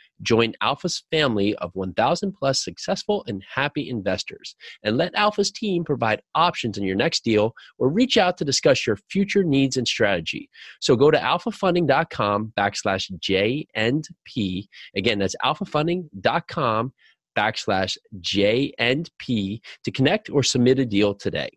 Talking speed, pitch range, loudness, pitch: 135 wpm, 105-170 Hz, -22 LUFS, 130 Hz